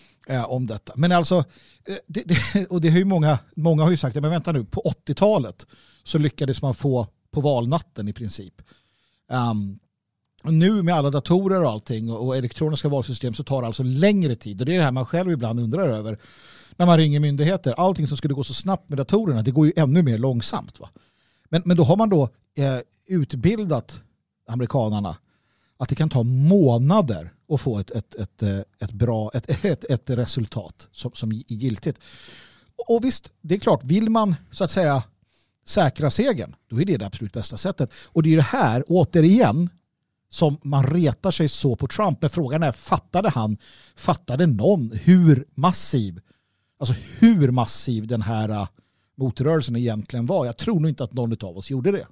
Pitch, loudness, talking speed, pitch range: 140 Hz, -22 LUFS, 180 wpm, 115-170 Hz